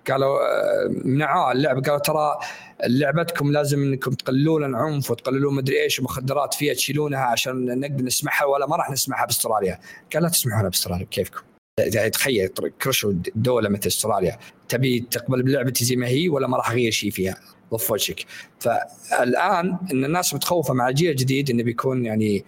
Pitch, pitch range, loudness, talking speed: 135 Hz, 125-145 Hz, -22 LUFS, 155 wpm